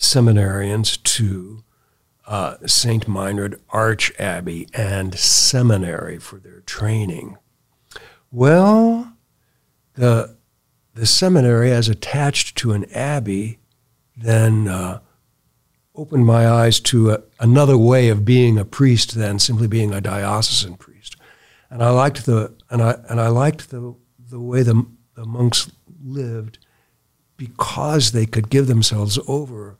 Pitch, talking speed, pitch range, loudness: 115 Hz, 125 wpm, 110-130 Hz, -17 LUFS